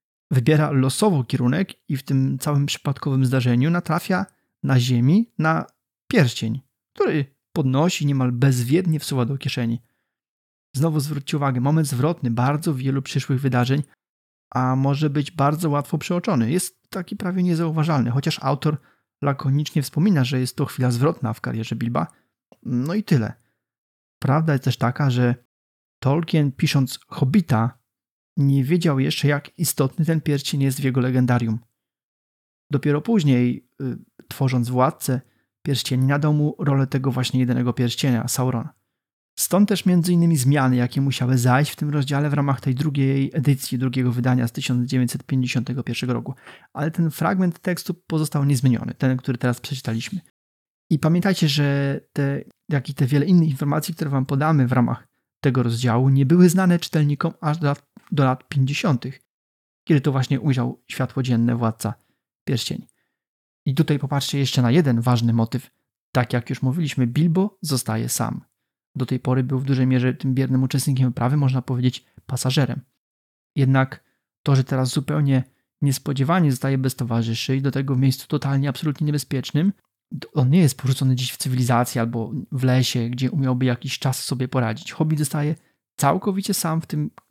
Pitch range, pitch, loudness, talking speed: 125-150 Hz, 135 Hz, -21 LUFS, 155 wpm